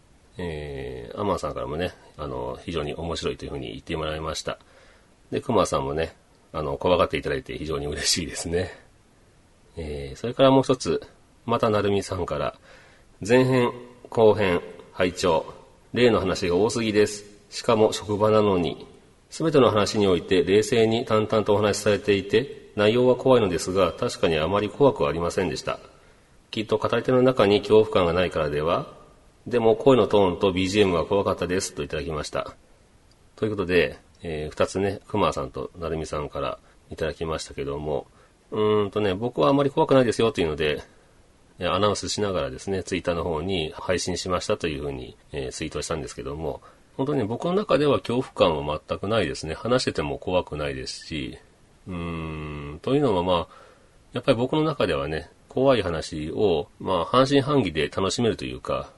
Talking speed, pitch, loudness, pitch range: 370 characters per minute, 105 Hz, -24 LUFS, 90-120 Hz